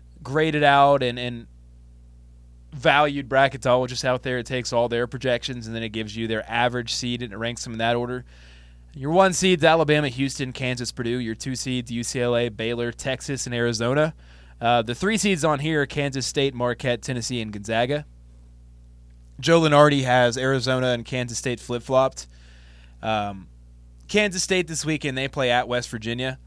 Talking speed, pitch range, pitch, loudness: 175 wpm, 115-135 Hz, 125 Hz, -23 LUFS